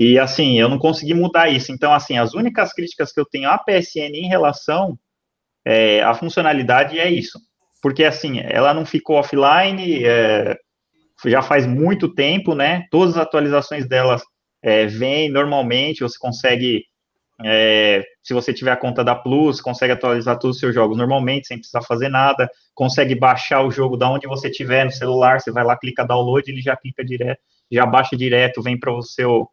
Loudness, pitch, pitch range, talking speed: -17 LUFS, 130 Hz, 125-150 Hz, 185 wpm